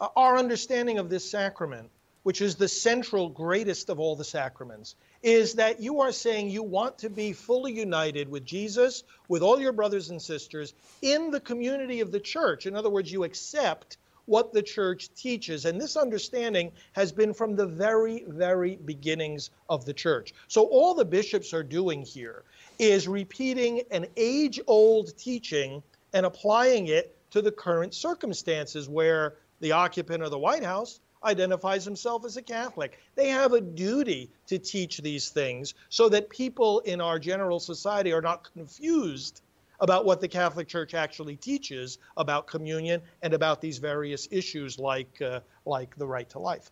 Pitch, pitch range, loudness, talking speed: 190 Hz, 160-230 Hz, -27 LUFS, 170 wpm